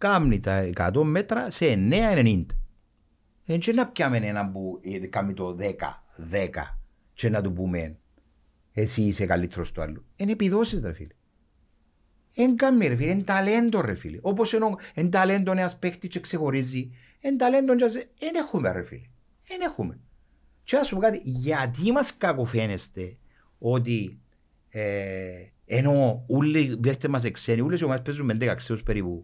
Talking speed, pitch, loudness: 135 wpm, 120 Hz, -25 LUFS